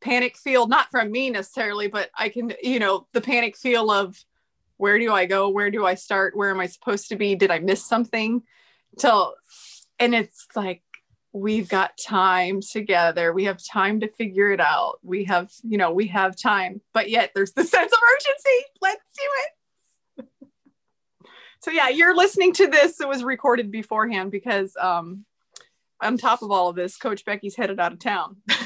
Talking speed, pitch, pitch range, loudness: 185 wpm, 210 Hz, 195-245 Hz, -21 LUFS